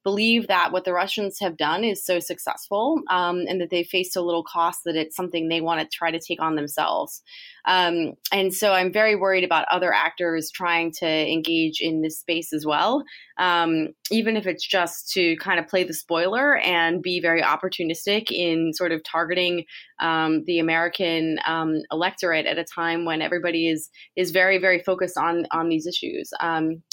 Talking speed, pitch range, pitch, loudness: 190 wpm, 165-185 Hz, 170 Hz, -23 LUFS